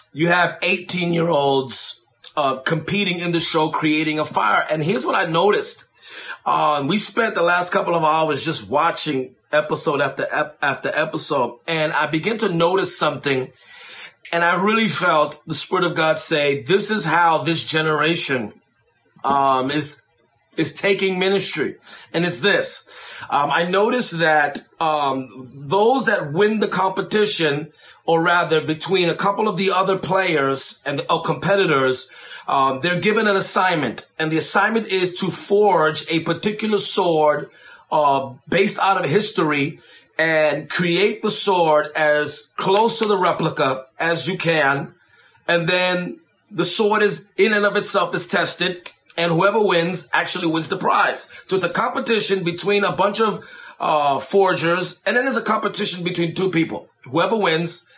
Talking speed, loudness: 155 wpm, -19 LUFS